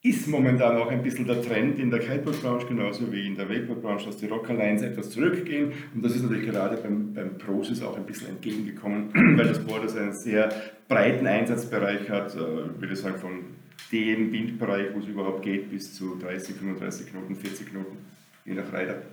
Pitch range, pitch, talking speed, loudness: 100-120 Hz, 105 Hz, 195 wpm, -27 LUFS